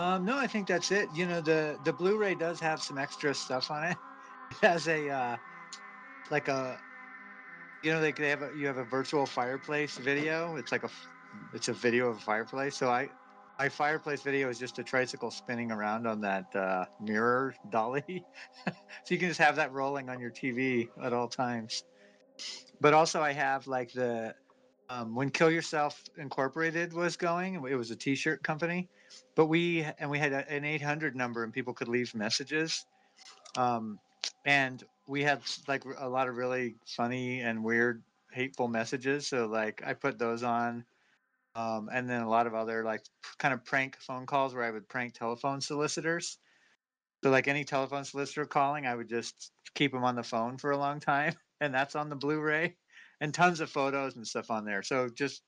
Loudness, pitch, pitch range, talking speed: -32 LUFS, 135 Hz, 120-150 Hz, 190 wpm